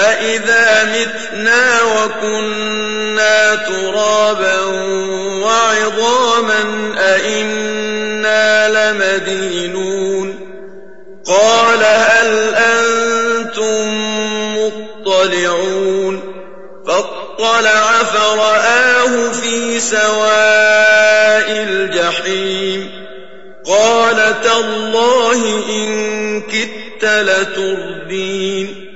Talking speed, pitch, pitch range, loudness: 45 wpm, 215 Hz, 195-225 Hz, -12 LUFS